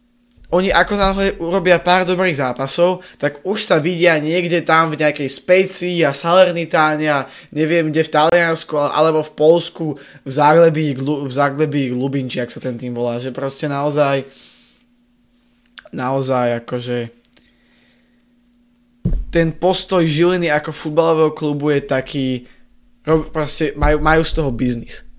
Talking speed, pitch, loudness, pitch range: 135 wpm, 155 Hz, -16 LUFS, 140-180 Hz